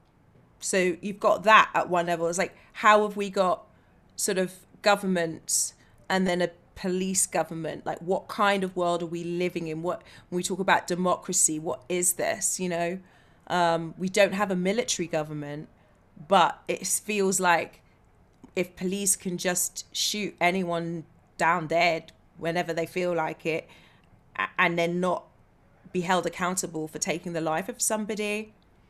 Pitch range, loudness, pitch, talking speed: 165-190 Hz, -26 LUFS, 180 Hz, 160 wpm